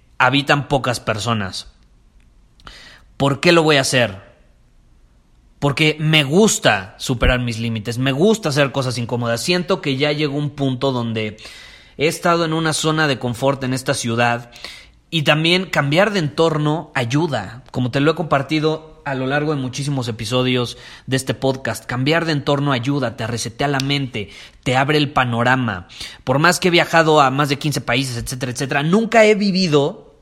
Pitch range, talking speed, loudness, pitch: 120-155 Hz, 165 wpm, -18 LUFS, 140 Hz